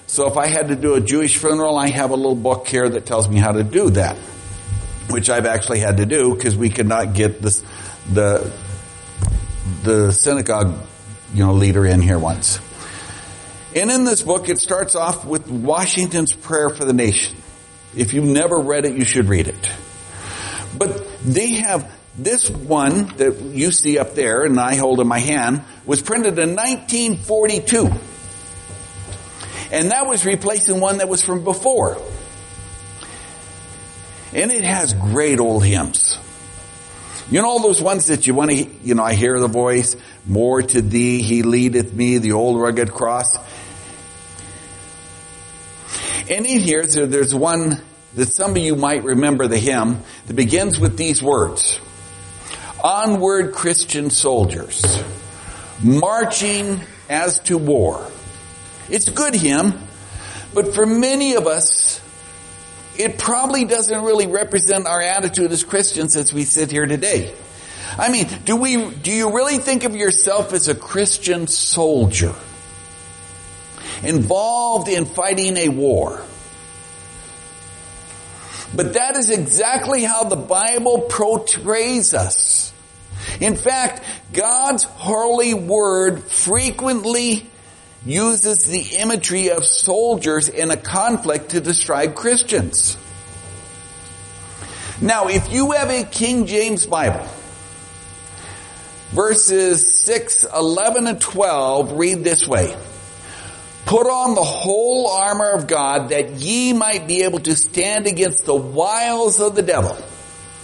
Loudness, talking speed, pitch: -16 LUFS, 140 wpm, 135 Hz